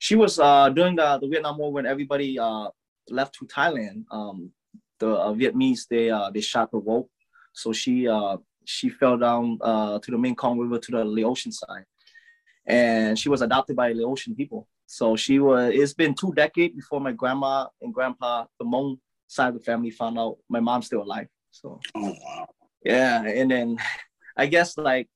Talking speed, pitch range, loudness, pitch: 185 wpm, 115-170 Hz, -24 LUFS, 130 Hz